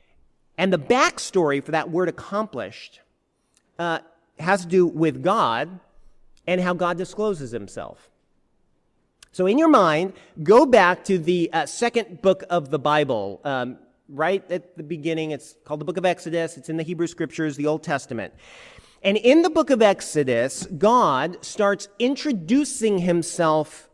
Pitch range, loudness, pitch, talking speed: 155-195 Hz, -22 LUFS, 175 Hz, 155 wpm